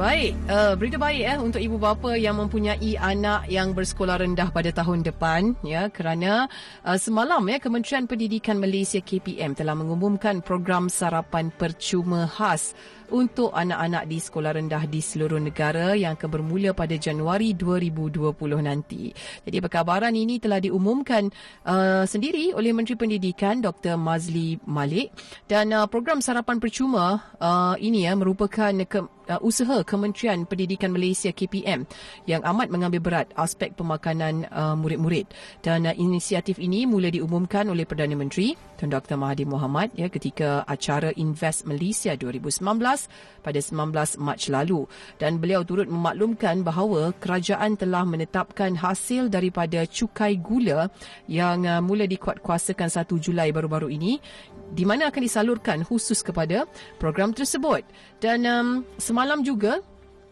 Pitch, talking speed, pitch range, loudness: 185 Hz, 135 wpm, 165-210 Hz, -24 LUFS